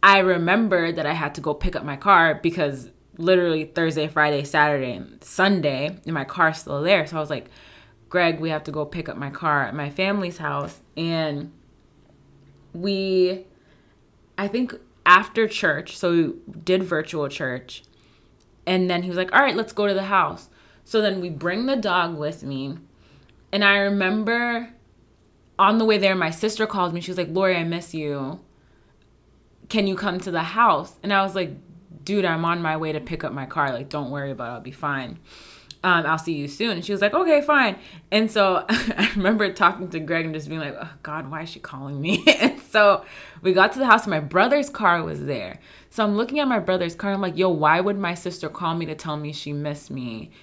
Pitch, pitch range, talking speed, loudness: 175 Hz, 150-195 Hz, 215 wpm, -22 LUFS